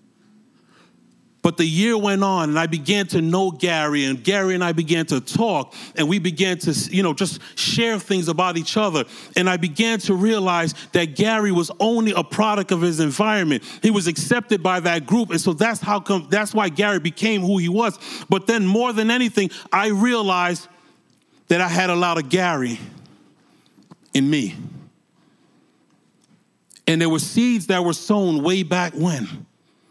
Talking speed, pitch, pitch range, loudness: 175 wpm, 185 Hz, 170-210 Hz, -20 LUFS